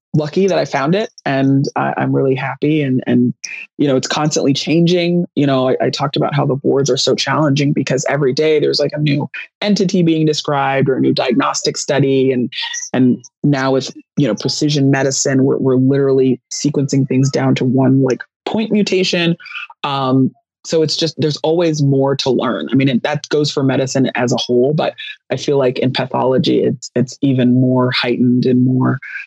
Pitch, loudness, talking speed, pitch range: 140 Hz, -15 LUFS, 195 wpm, 130-155 Hz